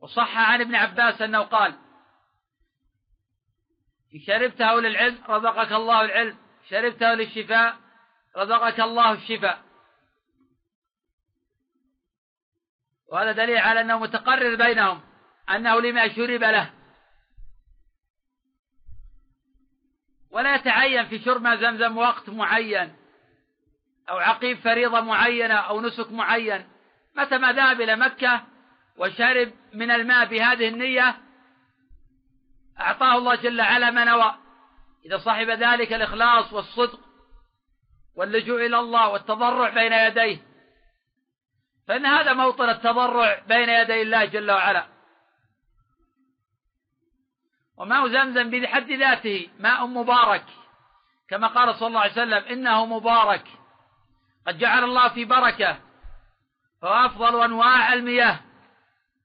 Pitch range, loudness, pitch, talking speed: 225-250 Hz, -20 LUFS, 235 Hz, 100 wpm